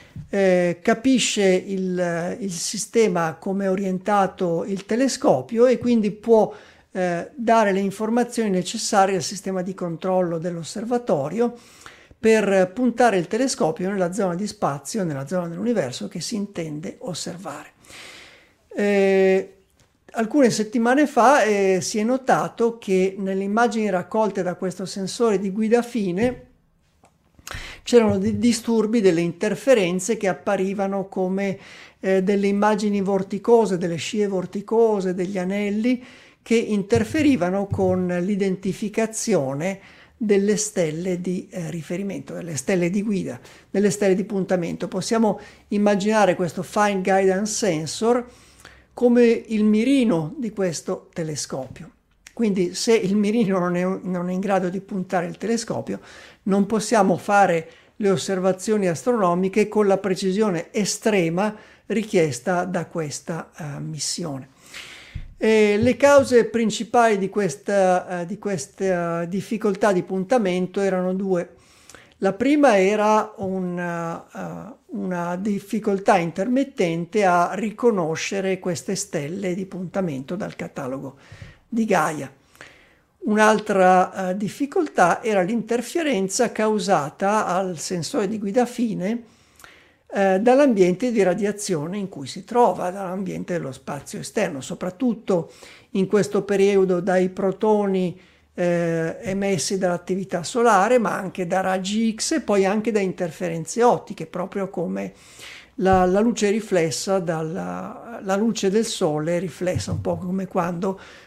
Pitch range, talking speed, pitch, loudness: 180-220 Hz, 120 wpm, 195 Hz, -22 LUFS